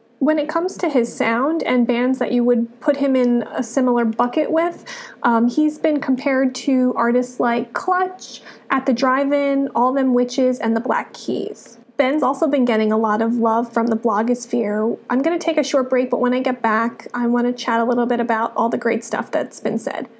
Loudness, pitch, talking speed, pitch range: -19 LUFS, 245 Hz, 215 wpm, 235-275 Hz